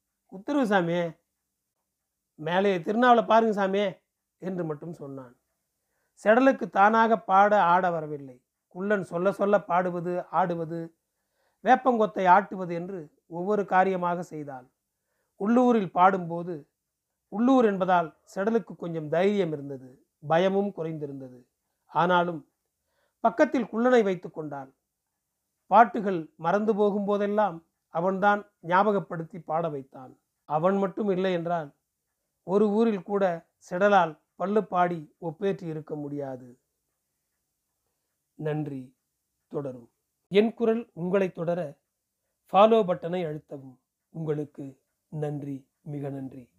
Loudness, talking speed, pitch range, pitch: -25 LUFS, 95 wpm, 155-205 Hz, 180 Hz